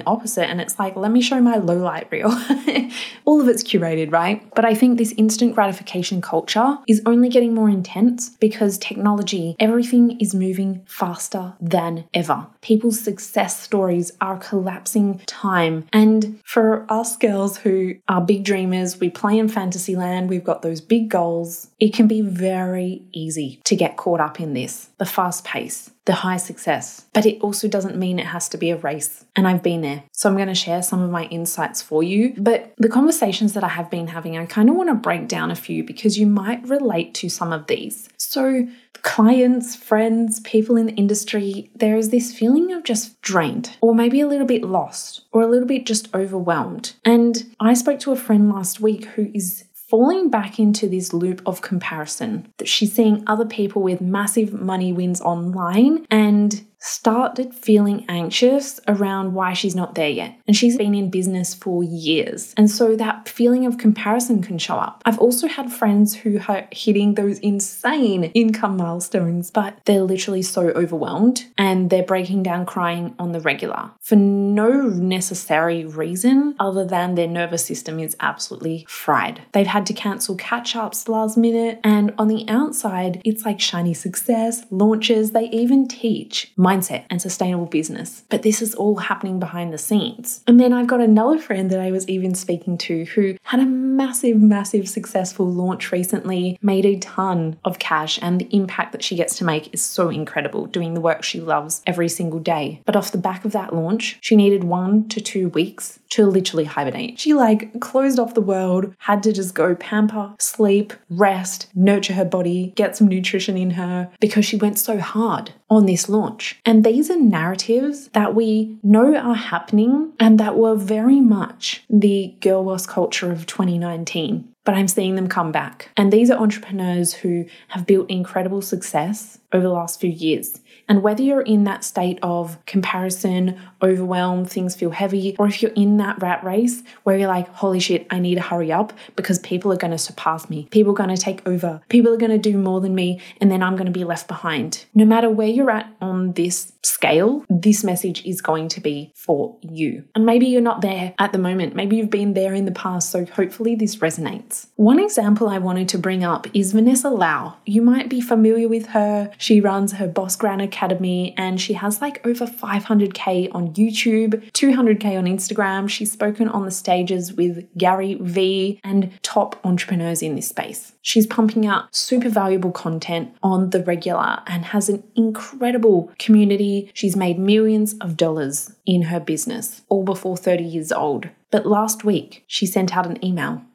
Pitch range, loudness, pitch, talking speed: 180-225 Hz, -19 LUFS, 200 Hz, 190 wpm